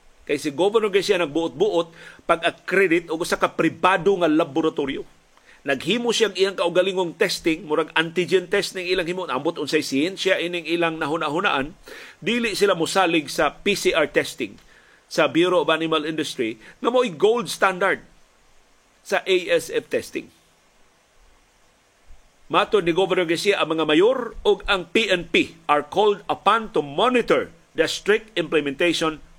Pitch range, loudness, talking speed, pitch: 160-205 Hz, -21 LUFS, 135 wpm, 180 Hz